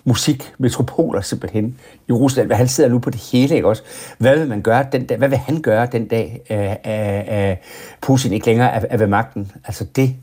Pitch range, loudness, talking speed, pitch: 105-130 Hz, -17 LUFS, 195 wpm, 120 Hz